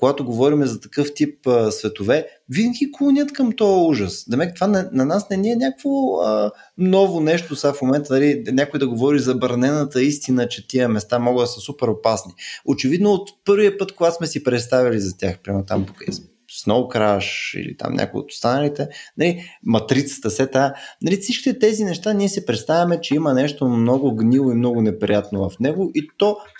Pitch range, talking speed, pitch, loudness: 120-190 Hz, 185 wpm, 140 Hz, -19 LUFS